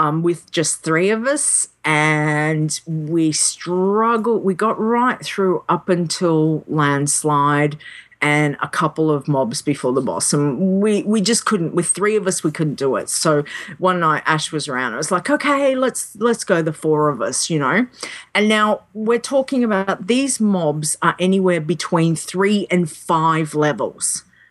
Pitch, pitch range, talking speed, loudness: 170 Hz, 155-210 Hz, 170 wpm, -18 LUFS